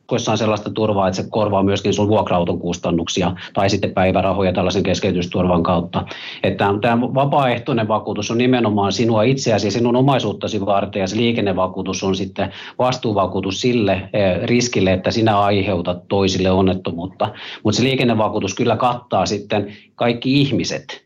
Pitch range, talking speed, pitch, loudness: 95-115 Hz, 145 wpm, 100 Hz, -18 LUFS